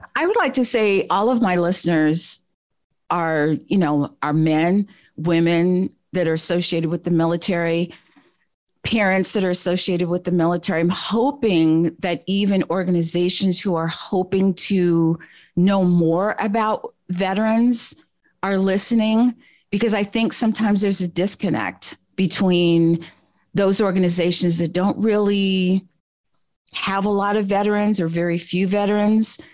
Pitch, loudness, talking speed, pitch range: 185 Hz, -19 LUFS, 130 wpm, 170-205 Hz